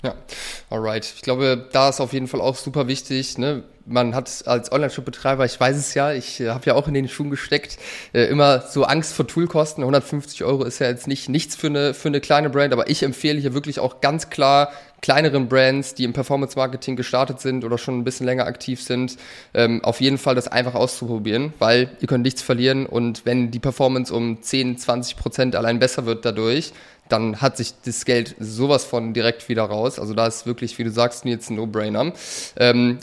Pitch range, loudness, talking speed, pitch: 120-140 Hz, -21 LUFS, 215 wpm, 130 Hz